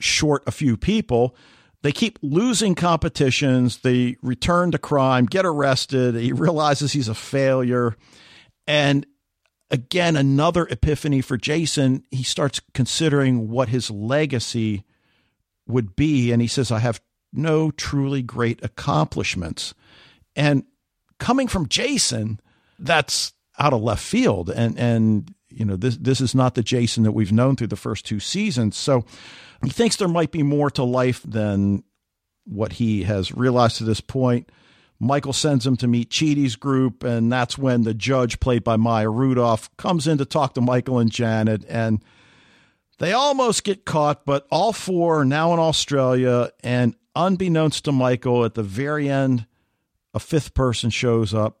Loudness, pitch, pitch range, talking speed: -21 LUFS, 130 Hz, 115-145 Hz, 155 wpm